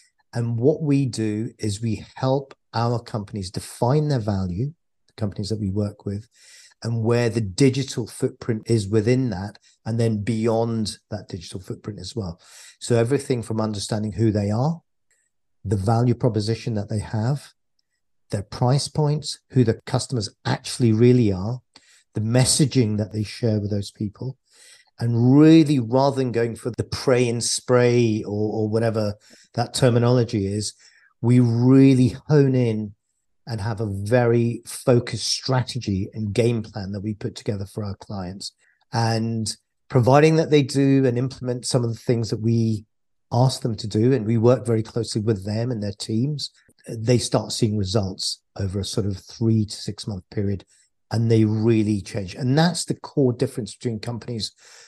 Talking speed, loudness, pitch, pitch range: 165 wpm, -22 LUFS, 115 Hz, 105-125 Hz